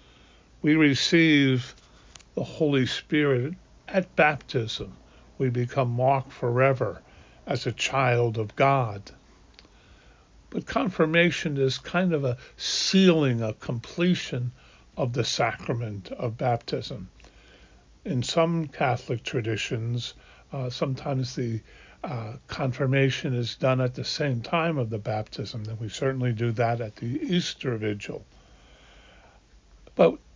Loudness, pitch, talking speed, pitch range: -26 LUFS, 130 Hz, 115 wpm, 115-145 Hz